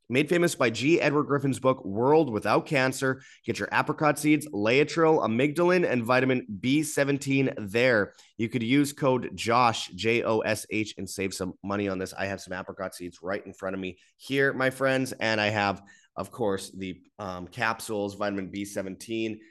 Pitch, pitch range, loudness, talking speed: 115 Hz, 100-135 Hz, -26 LUFS, 180 wpm